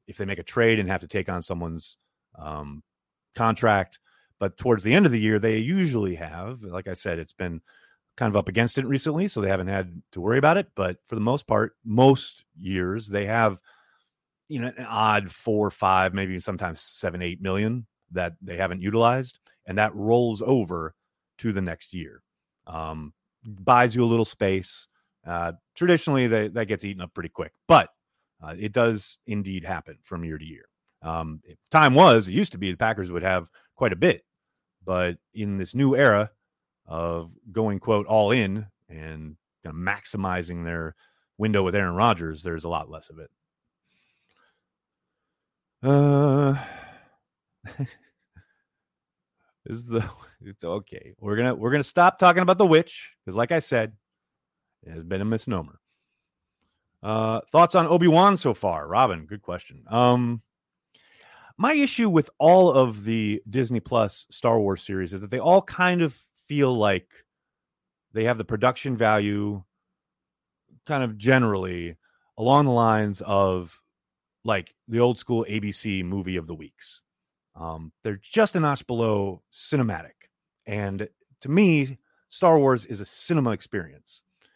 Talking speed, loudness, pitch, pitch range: 165 wpm, -23 LUFS, 105 Hz, 95-125 Hz